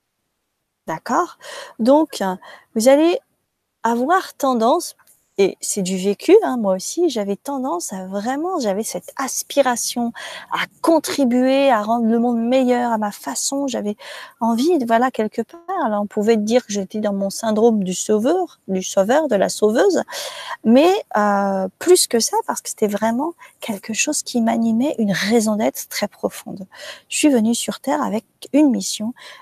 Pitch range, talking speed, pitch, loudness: 210-285 Hz, 155 wpm, 235 Hz, -19 LUFS